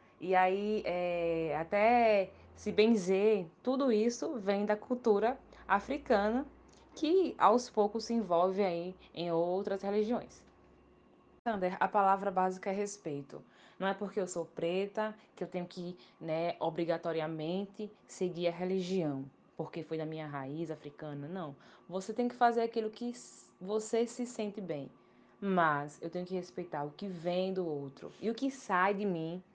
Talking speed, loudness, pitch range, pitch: 150 wpm, -34 LUFS, 170-215 Hz, 190 Hz